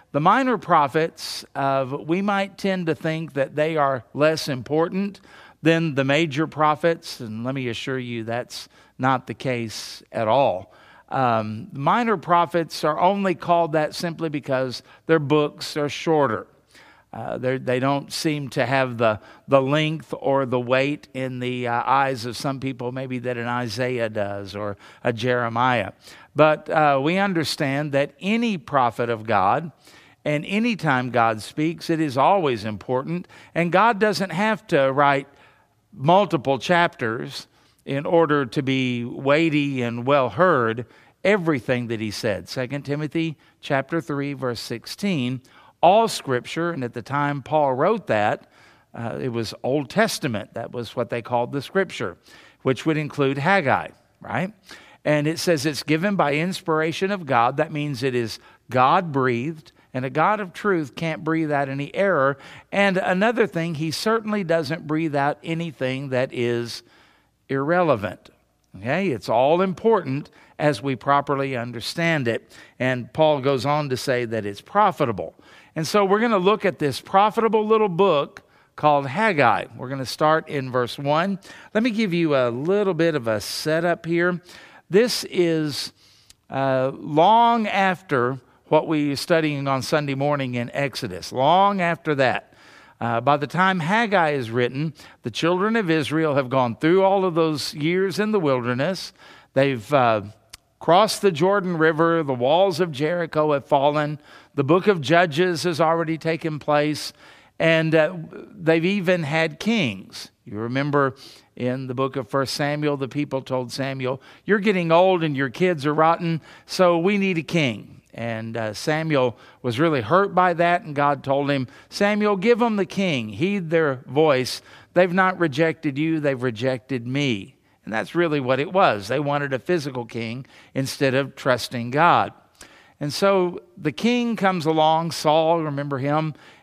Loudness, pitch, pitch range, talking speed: -22 LUFS, 150 Hz, 130-170 Hz, 160 wpm